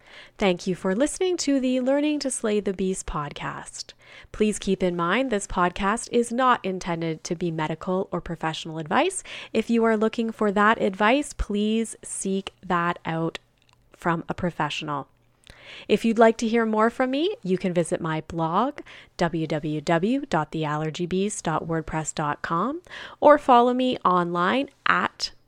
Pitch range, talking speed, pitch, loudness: 165-230 Hz, 140 wpm, 190 Hz, -24 LUFS